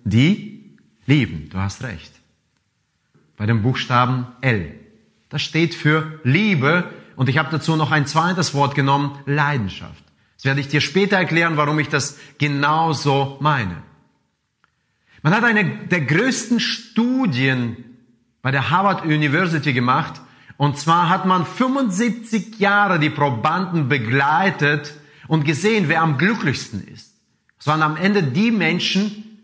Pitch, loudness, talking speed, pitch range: 150 Hz, -19 LUFS, 135 wpm, 135-185 Hz